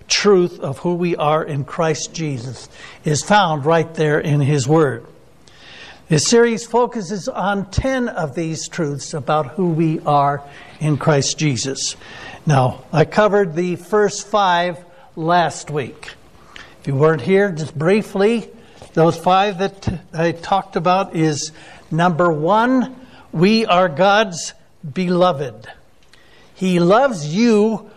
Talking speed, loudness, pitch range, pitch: 130 wpm, -17 LUFS, 155-200 Hz, 175 Hz